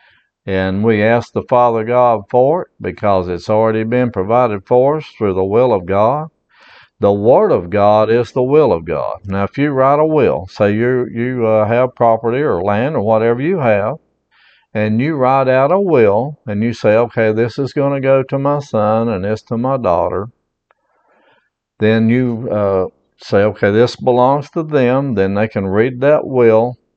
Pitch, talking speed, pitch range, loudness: 115 Hz, 185 wpm, 110-130 Hz, -14 LUFS